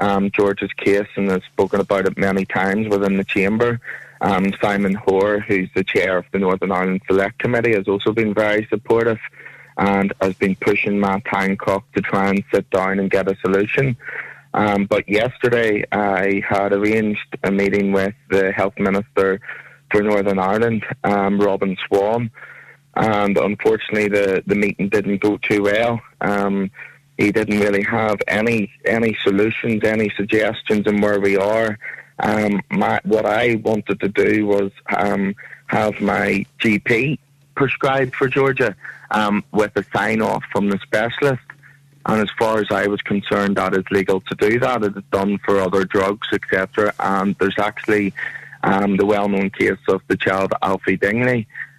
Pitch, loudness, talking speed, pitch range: 100 Hz, -18 LUFS, 160 wpm, 100-110 Hz